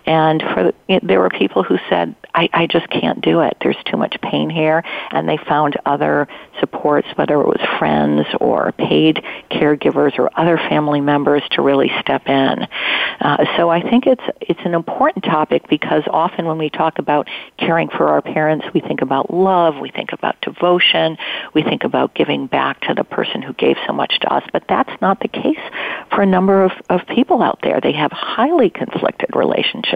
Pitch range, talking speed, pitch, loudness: 145-175 Hz, 195 wpm, 155 Hz, -16 LUFS